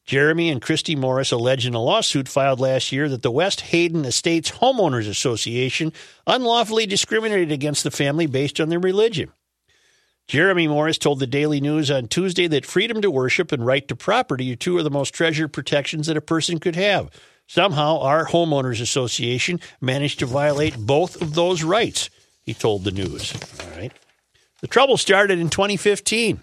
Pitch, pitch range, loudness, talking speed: 150 Hz, 135-175 Hz, -20 LUFS, 175 wpm